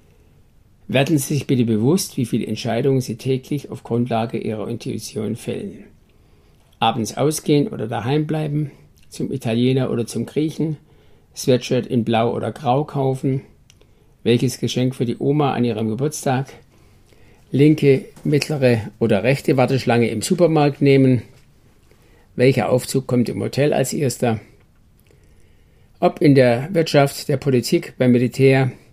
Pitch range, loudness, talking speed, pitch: 115-140 Hz, -19 LUFS, 130 wpm, 125 Hz